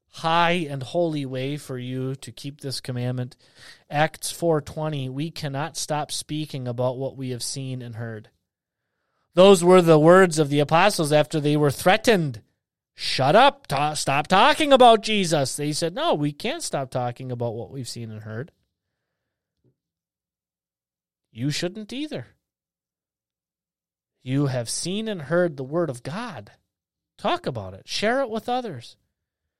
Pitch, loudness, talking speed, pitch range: 140 Hz, -22 LUFS, 150 wpm, 125-170 Hz